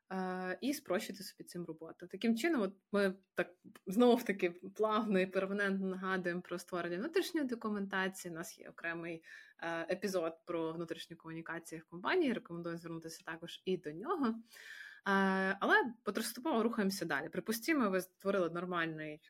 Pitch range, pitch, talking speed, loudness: 170-215 Hz, 185 Hz, 150 wpm, -37 LUFS